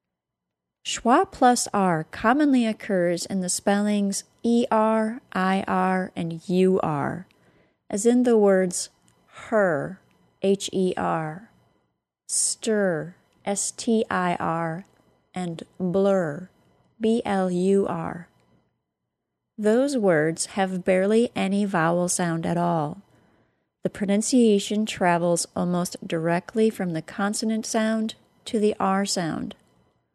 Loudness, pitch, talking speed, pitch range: -23 LUFS, 195 Hz, 90 wpm, 175-220 Hz